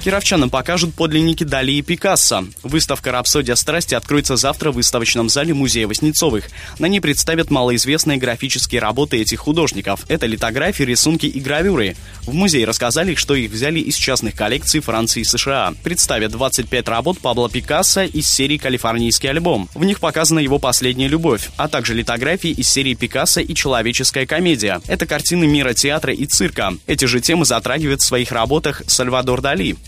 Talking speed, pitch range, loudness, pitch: 160 wpm, 120-155 Hz, -16 LUFS, 140 Hz